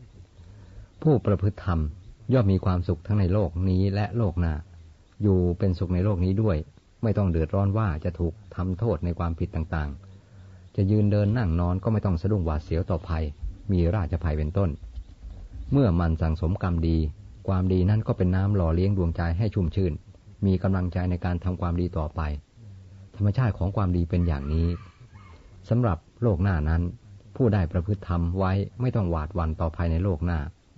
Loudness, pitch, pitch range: -26 LUFS, 95 Hz, 85-100 Hz